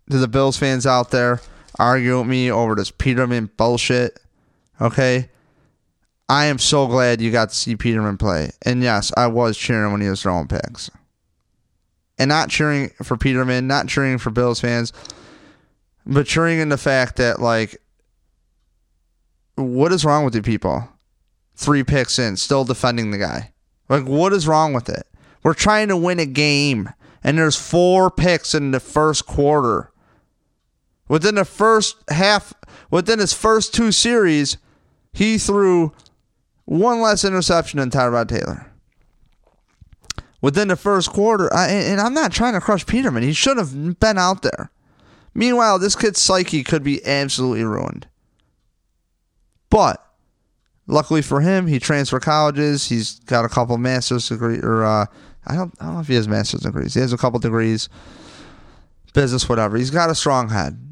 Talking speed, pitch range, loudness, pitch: 165 wpm, 115-160 Hz, -18 LUFS, 130 Hz